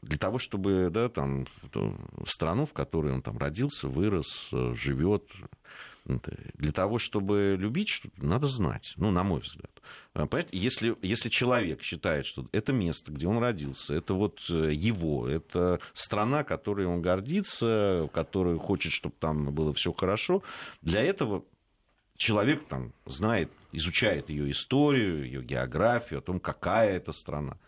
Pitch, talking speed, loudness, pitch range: 95 Hz, 140 wpm, -30 LUFS, 75-115 Hz